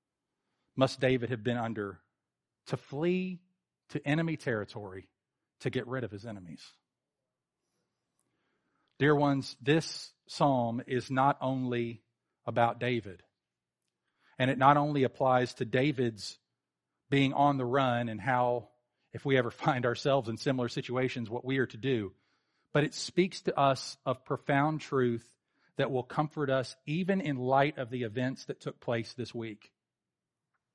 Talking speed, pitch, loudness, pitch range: 145 wpm, 130 Hz, -31 LUFS, 120-140 Hz